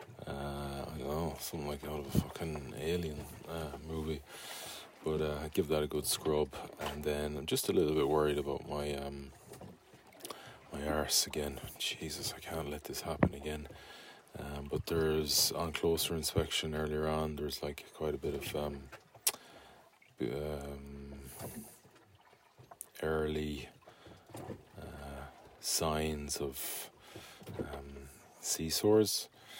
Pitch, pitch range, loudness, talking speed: 75 Hz, 70-80 Hz, -36 LUFS, 130 wpm